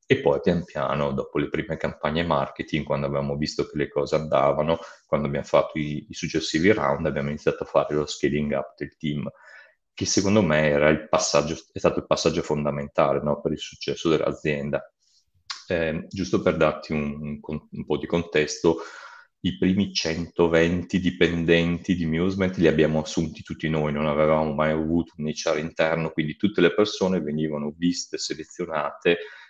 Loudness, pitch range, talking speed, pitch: -24 LUFS, 75-85 Hz, 170 wpm, 80 Hz